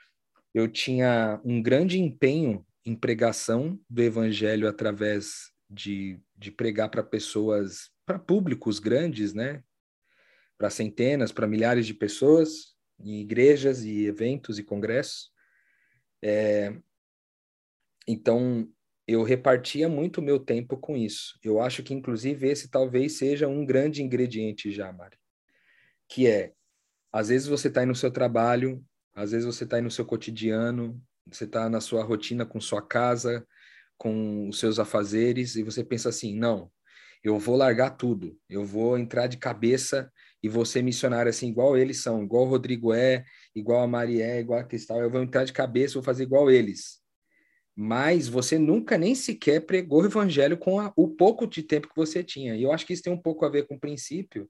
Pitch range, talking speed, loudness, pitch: 110-135 Hz, 170 wpm, -26 LUFS, 120 Hz